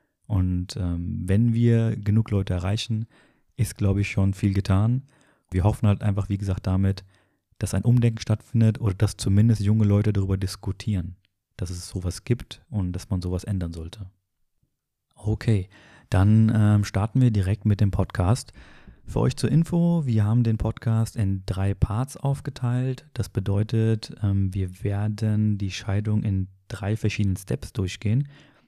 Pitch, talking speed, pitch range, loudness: 105 Hz, 155 wpm, 95-115 Hz, -24 LUFS